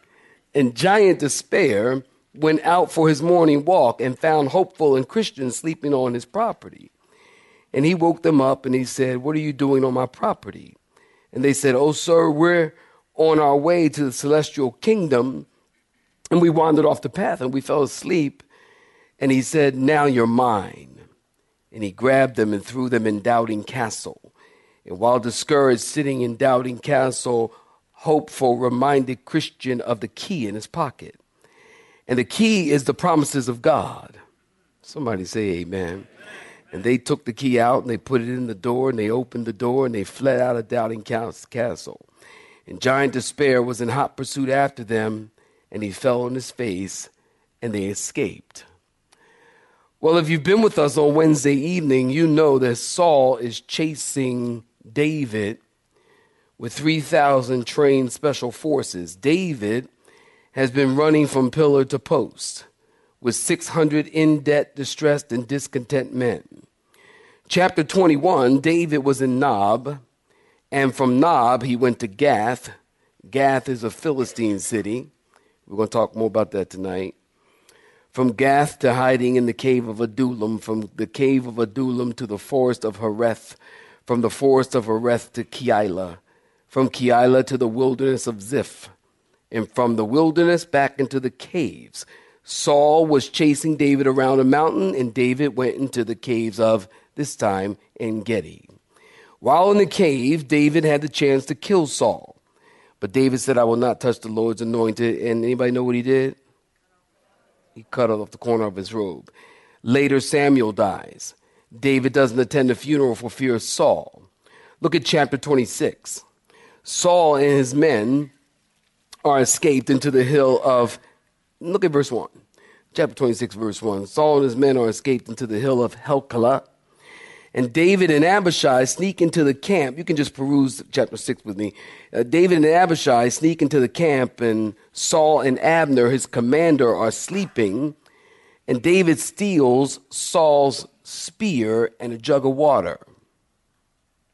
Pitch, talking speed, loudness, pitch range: 135 Hz, 160 wpm, -20 LUFS, 120-150 Hz